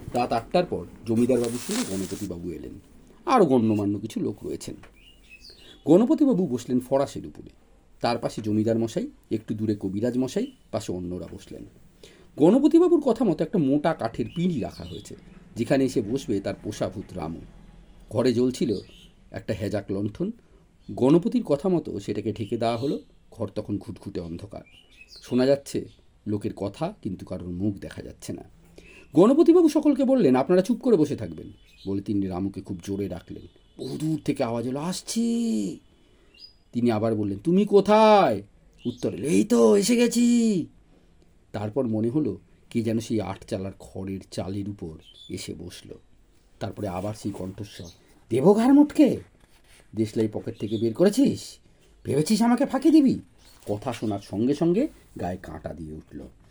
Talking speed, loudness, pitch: 140 wpm, -24 LUFS, 115 Hz